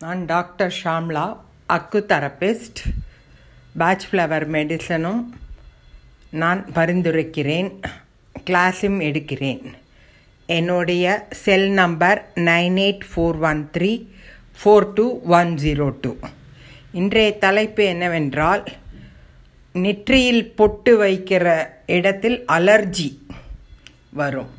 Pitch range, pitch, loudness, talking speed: 150-195 Hz, 175 Hz, -19 LUFS, 80 wpm